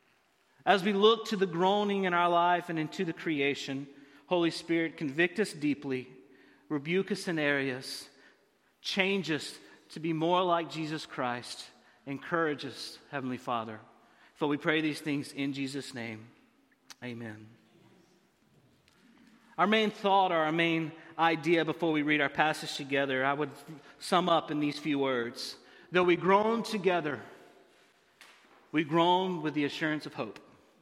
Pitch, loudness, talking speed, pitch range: 155 Hz, -30 LUFS, 145 wpm, 140-175 Hz